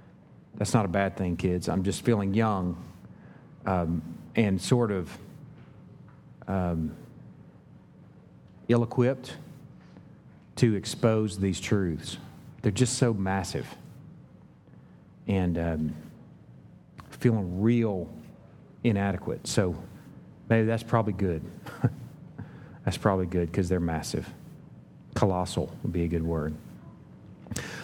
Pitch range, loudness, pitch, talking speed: 90-120 Hz, -28 LUFS, 100 Hz, 100 wpm